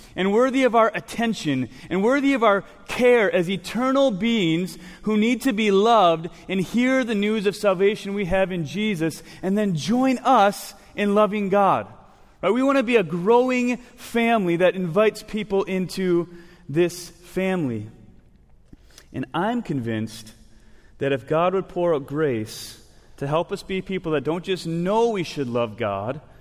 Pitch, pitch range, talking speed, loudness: 185 Hz, 160-215 Hz, 165 wpm, -22 LUFS